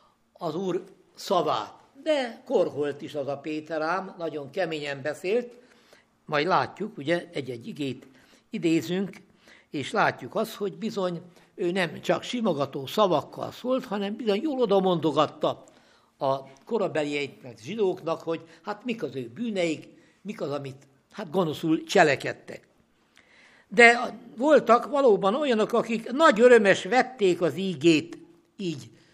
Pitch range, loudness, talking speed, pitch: 155-220 Hz, -26 LUFS, 120 wpm, 185 Hz